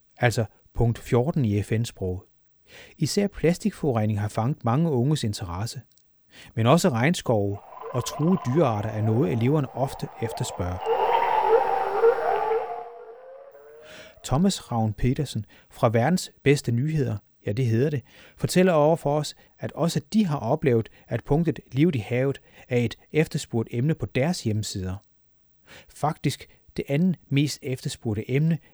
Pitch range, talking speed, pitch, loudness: 115-165 Hz, 130 wpm, 135 Hz, -25 LUFS